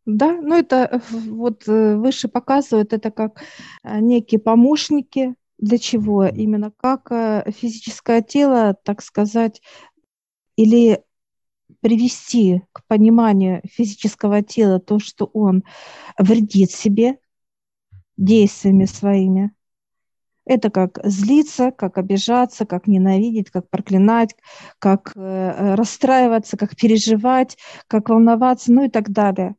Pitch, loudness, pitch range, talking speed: 220 Hz, -17 LUFS, 200-240 Hz, 100 wpm